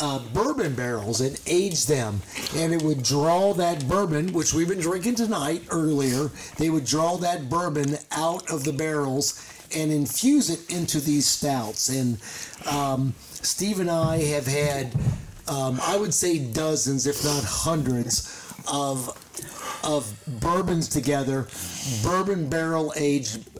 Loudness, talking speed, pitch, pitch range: -25 LUFS, 140 wpm, 150 Hz, 135-165 Hz